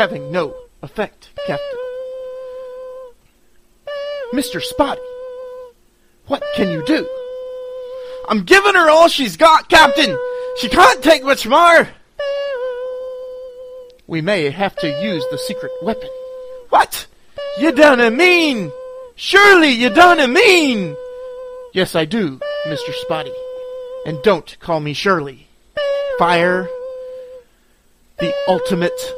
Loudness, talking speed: -14 LUFS, 105 wpm